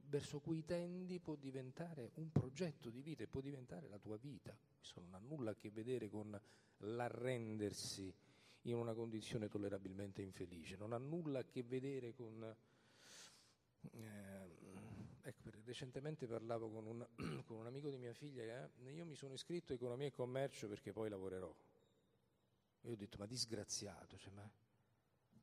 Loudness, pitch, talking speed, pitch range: -50 LUFS, 115 Hz, 165 wpm, 105-135 Hz